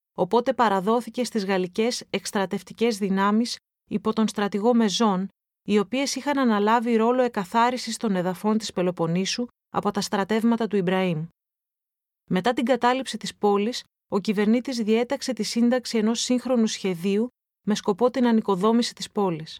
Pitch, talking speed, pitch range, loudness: 220 Hz, 135 wpm, 200-235 Hz, -24 LUFS